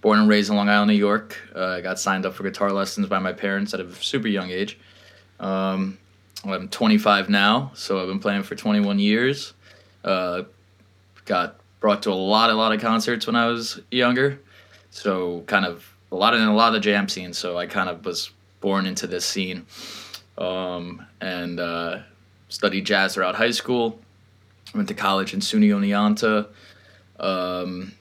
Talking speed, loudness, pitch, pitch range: 180 wpm, -22 LUFS, 100 Hz, 95-105 Hz